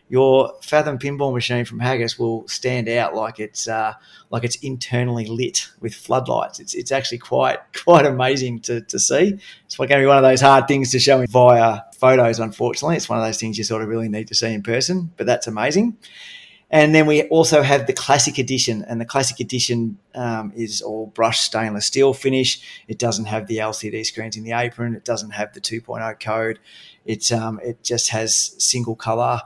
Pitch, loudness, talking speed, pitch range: 120 Hz, -19 LUFS, 205 wpm, 110-135 Hz